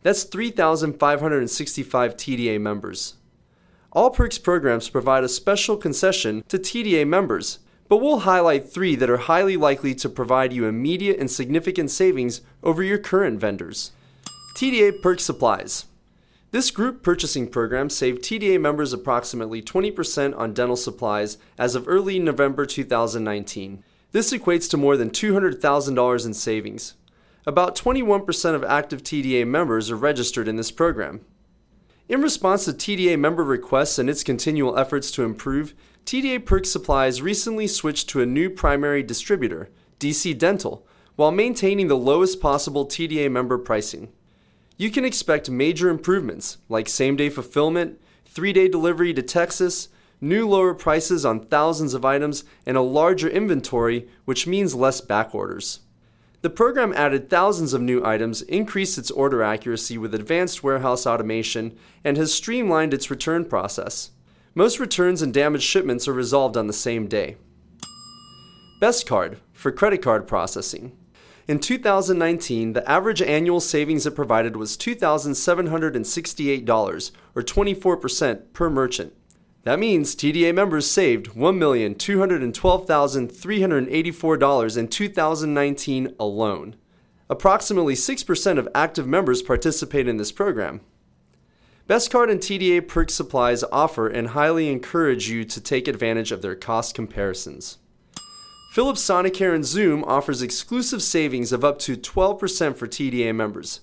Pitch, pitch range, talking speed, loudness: 150 Hz, 125-185 Hz, 135 wpm, -21 LUFS